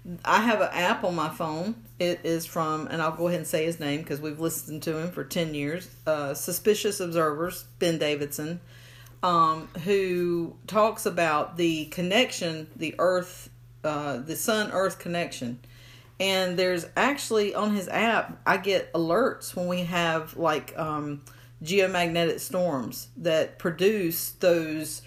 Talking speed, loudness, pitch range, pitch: 150 wpm, -27 LUFS, 150-180 Hz, 165 Hz